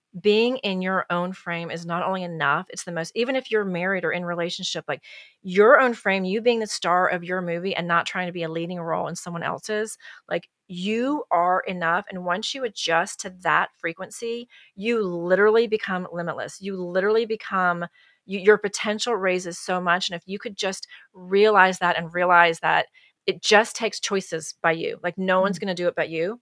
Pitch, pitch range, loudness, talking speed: 185 Hz, 175-210 Hz, -23 LUFS, 205 wpm